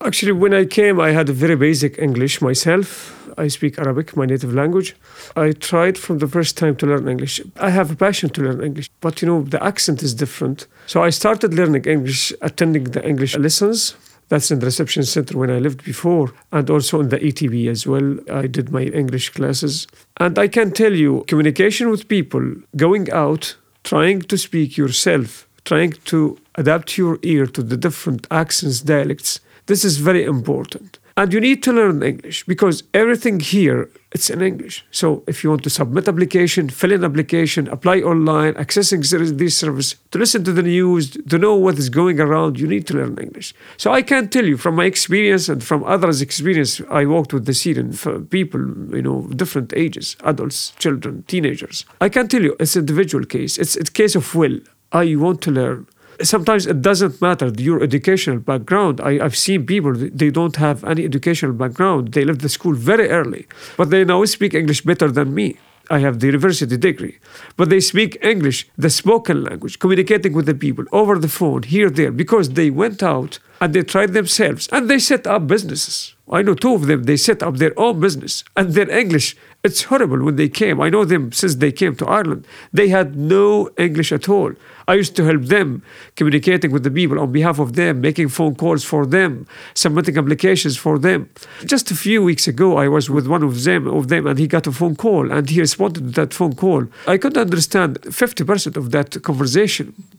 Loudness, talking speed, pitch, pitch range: -16 LUFS, 200 wpm, 165 Hz, 145-190 Hz